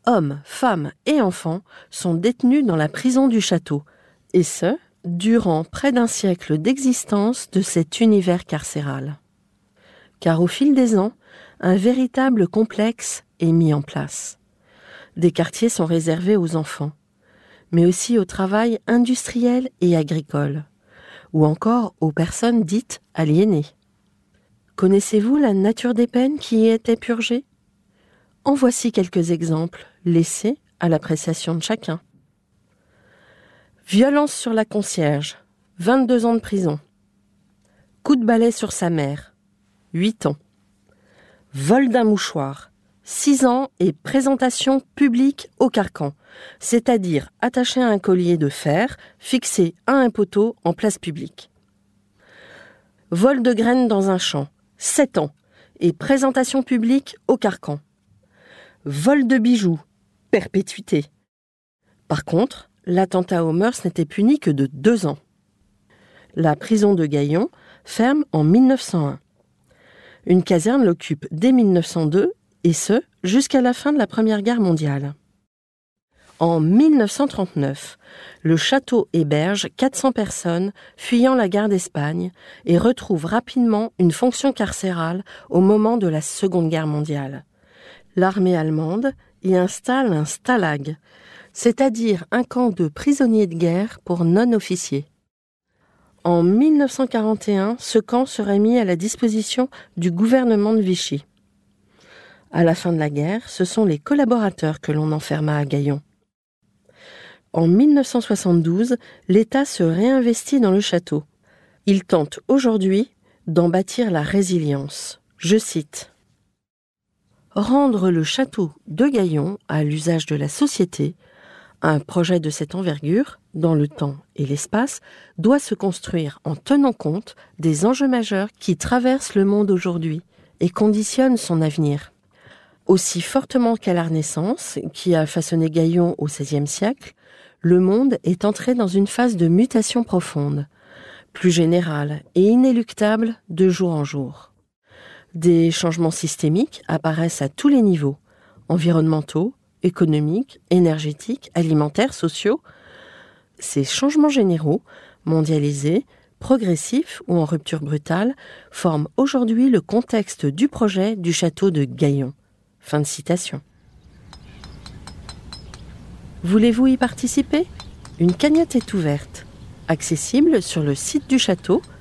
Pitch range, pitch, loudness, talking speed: 160-235 Hz, 185 Hz, -19 LUFS, 125 wpm